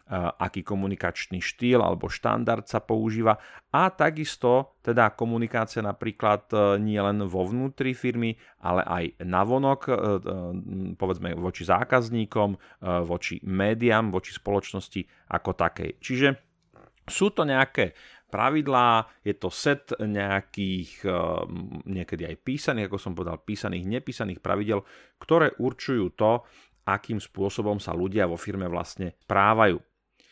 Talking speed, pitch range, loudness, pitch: 115 wpm, 95-120 Hz, -26 LUFS, 105 Hz